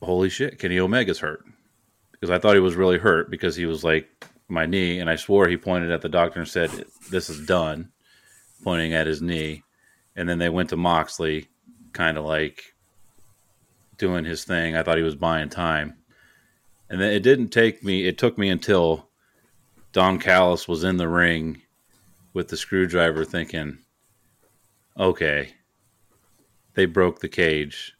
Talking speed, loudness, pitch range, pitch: 165 wpm, -22 LUFS, 80-95 Hz, 90 Hz